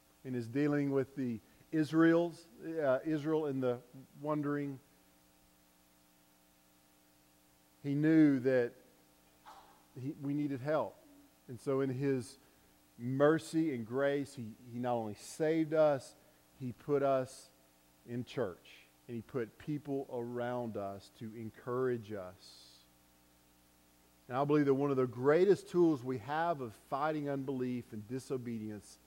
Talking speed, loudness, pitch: 125 wpm, -35 LUFS, 125 Hz